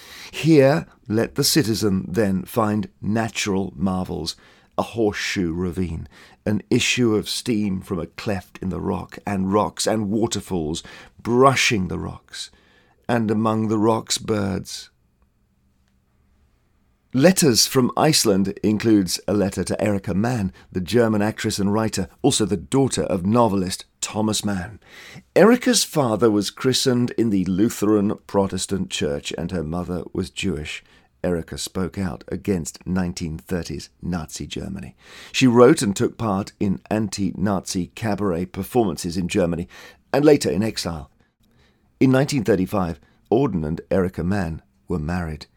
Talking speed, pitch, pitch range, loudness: 130 wpm, 100 Hz, 90-110 Hz, -21 LUFS